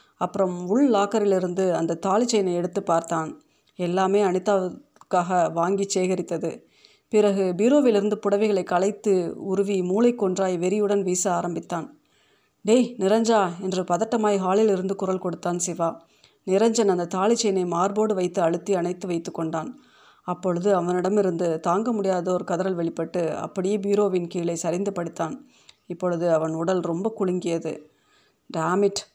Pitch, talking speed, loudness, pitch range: 190 Hz, 115 wpm, -24 LUFS, 175-205 Hz